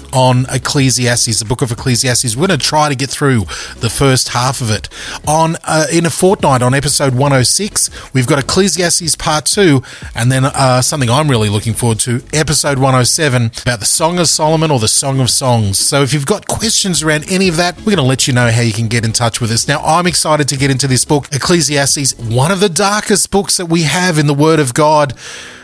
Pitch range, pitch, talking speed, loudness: 125-160 Hz, 140 Hz, 240 wpm, -11 LUFS